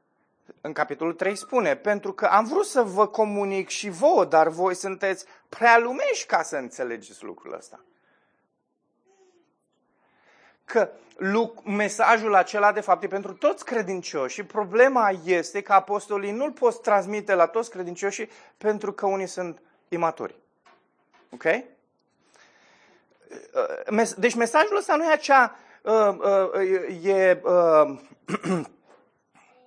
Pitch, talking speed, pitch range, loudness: 205 Hz, 110 wpm, 190-245 Hz, -23 LUFS